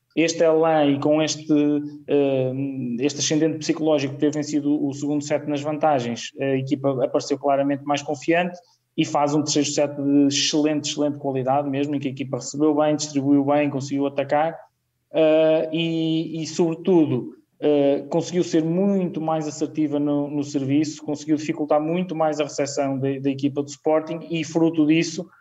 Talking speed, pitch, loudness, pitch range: 155 wpm, 150 Hz, -22 LUFS, 140-160 Hz